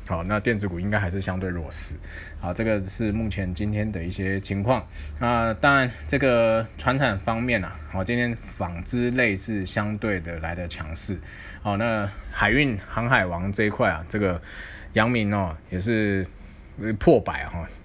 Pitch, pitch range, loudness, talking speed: 100 Hz, 90-115 Hz, -25 LUFS, 245 characters per minute